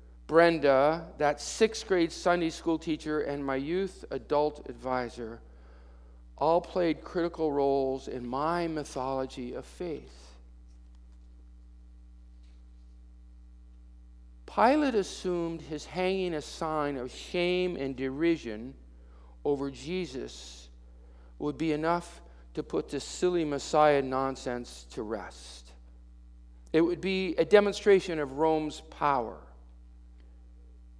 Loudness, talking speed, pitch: -30 LUFS, 100 wpm, 135 Hz